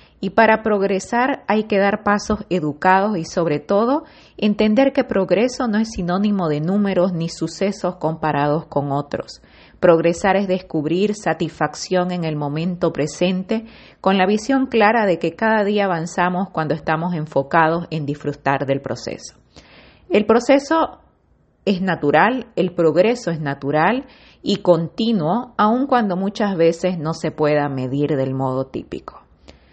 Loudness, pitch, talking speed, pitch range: -19 LUFS, 180 Hz, 140 wpm, 155-210 Hz